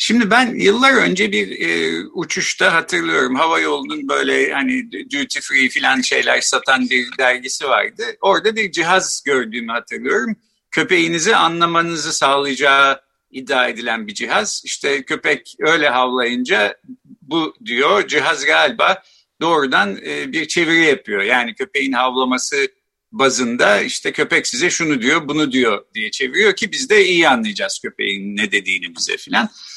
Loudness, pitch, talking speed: -16 LUFS, 165 Hz, 135 wpm